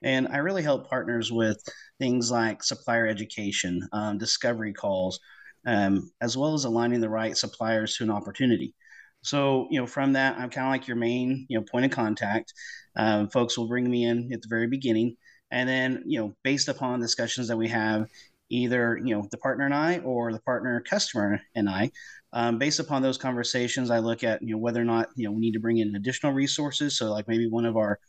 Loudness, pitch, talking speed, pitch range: -27 LUFS, 115 Hz, 215 wpm, 110-130 Hz